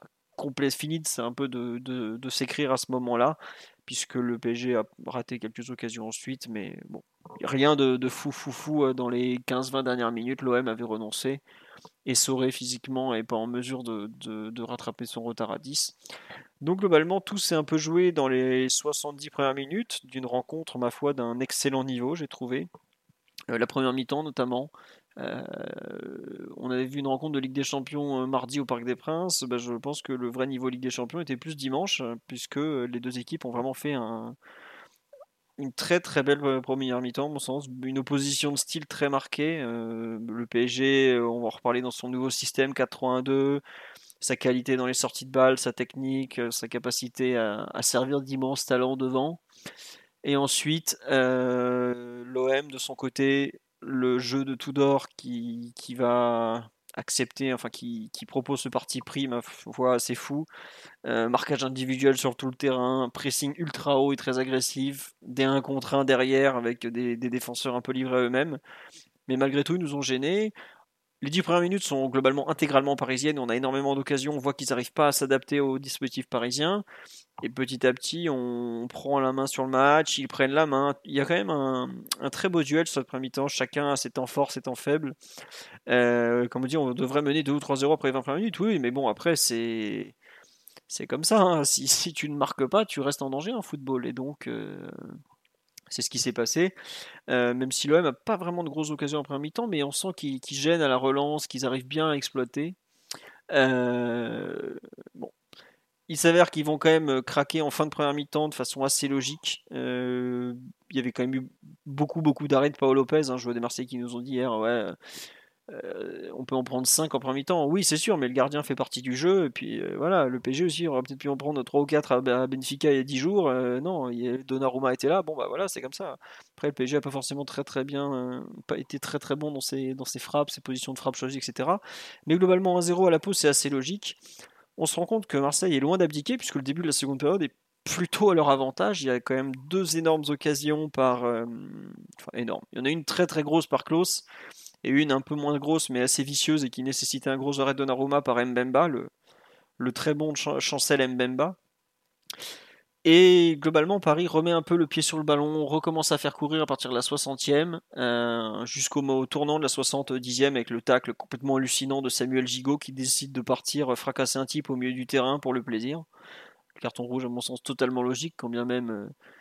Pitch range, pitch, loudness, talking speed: 125-150 Hz, 135 Hz, -27 LUFS, 215 wpm